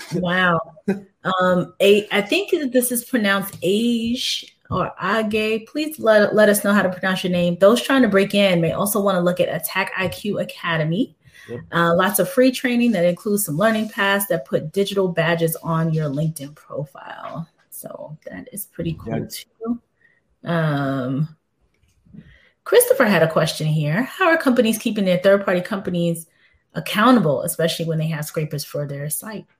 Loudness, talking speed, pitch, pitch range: -19 LUFS, 165 wpm, 190 Hz, 165-220 Hz